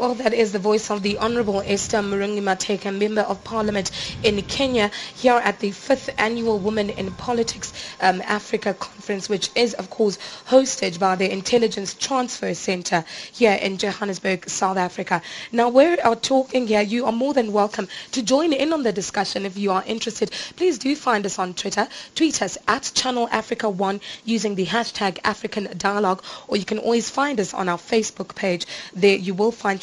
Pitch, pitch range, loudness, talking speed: 210 Hz, 195-235 Hz, -22 LUFS, 190 wpm